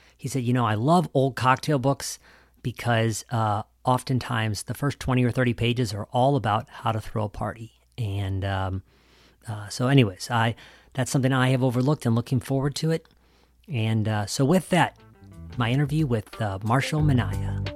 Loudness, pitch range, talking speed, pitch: -25 LUFS, 105-130 Hz, 180 wpm, 120 Hz